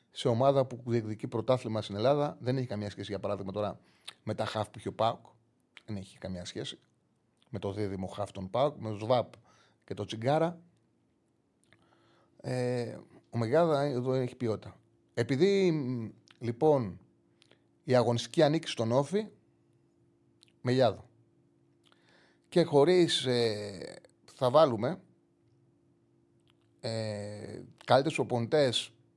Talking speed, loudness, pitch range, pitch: 115 wpm, -31 LUFS, 105-135 Hz, 120 Hz